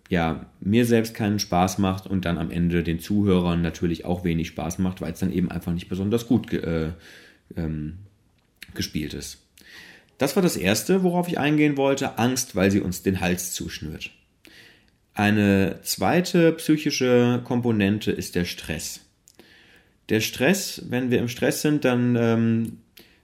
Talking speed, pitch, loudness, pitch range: 160 wpm, 100 Hz, -23 LUFS, 85-125 Hz